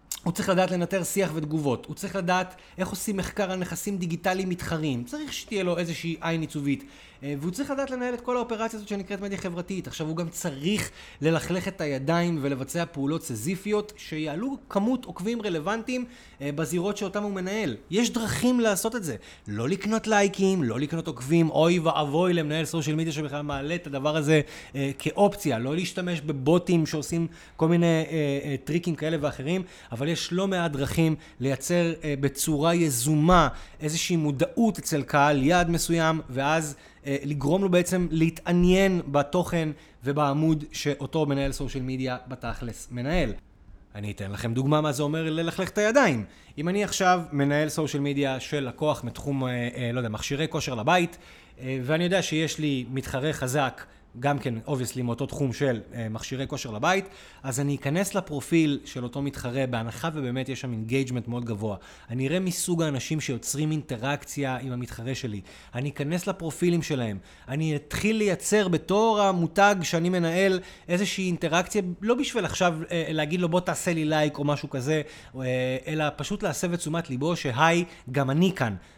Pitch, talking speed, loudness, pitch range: 160 Hz, 160 wpm, -27 LUFS, 140-180 Hz